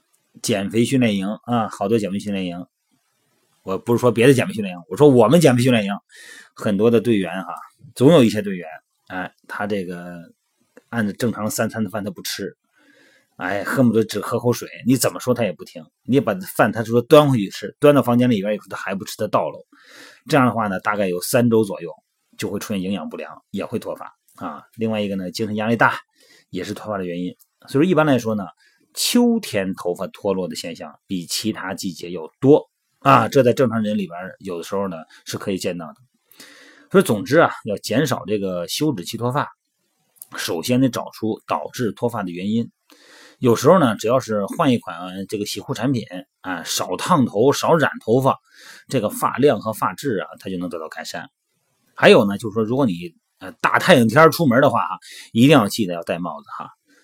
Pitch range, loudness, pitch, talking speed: 95-120 Hz, -19 LUFS, 110 Hz, 295 characters per minute